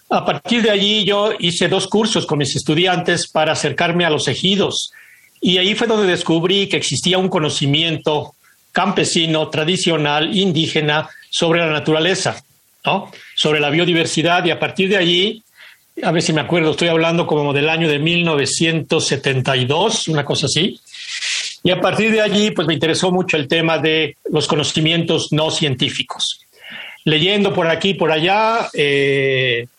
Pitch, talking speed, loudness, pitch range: 165 Hz, 155 wpm, -16 LUFS, 155-185 Hz